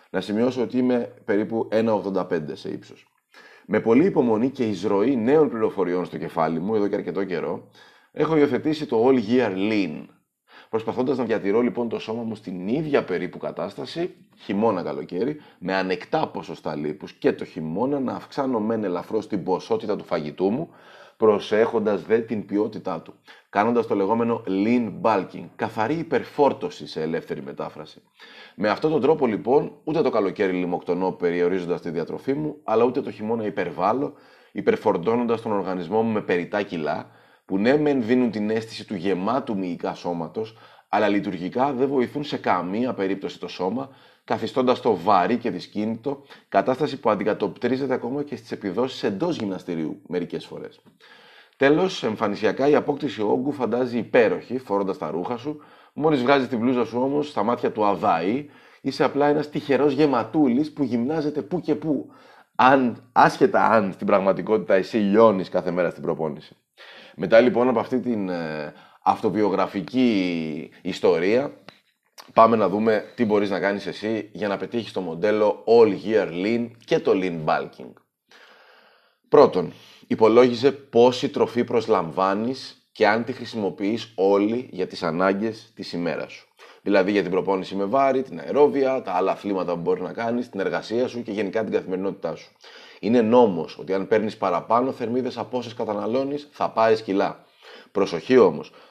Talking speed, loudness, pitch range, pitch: 155 wpm, -23 LUFS, 100-130 Hz, 115 Hz